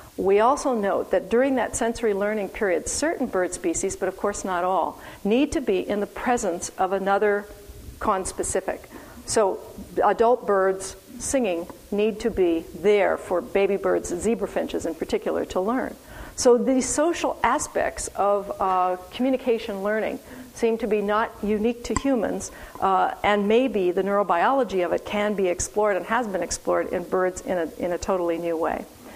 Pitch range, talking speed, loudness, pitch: 185-235 Hz, 165 wpm, -24 LUFS, 205 Hz